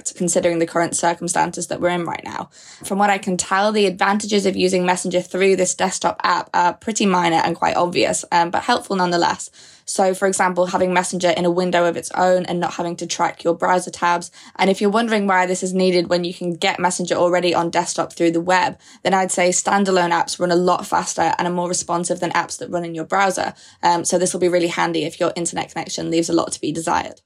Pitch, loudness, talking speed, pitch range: 180 Hz, -19 LUFS, 240 wpm, 175-185 Hz